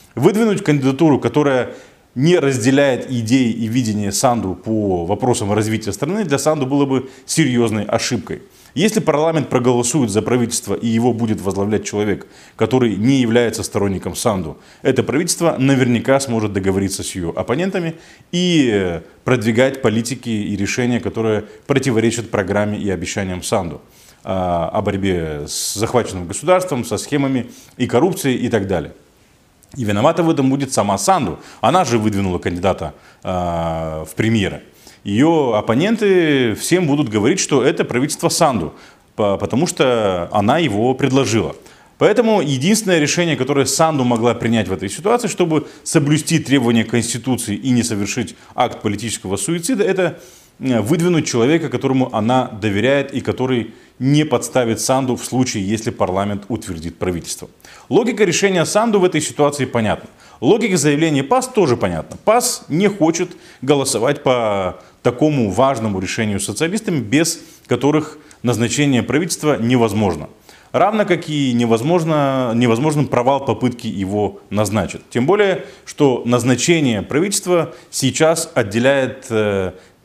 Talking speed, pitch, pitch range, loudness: 130 wpm, 125 Hz, 105-150 Hz, -17 LUFS